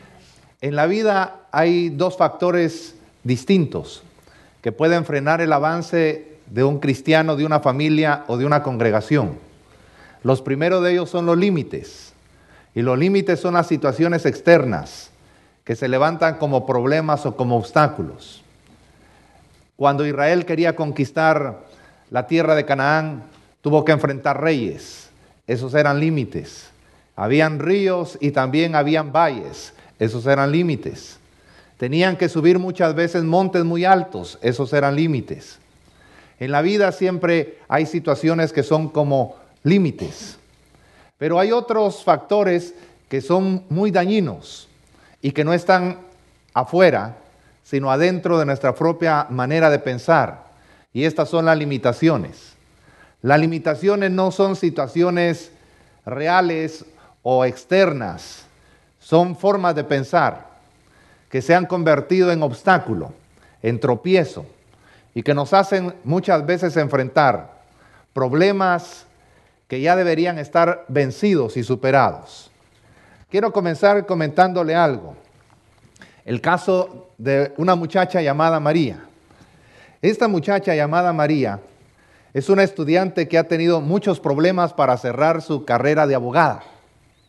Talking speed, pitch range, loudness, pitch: 125 wpm, 140-175 Hz, -19 LUFS, 160 Hz